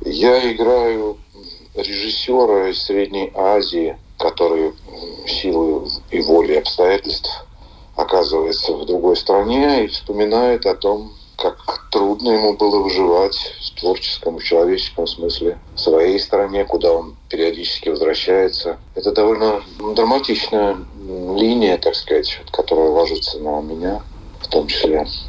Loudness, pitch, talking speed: -17 LUFS, 385 Hz, 115 wpm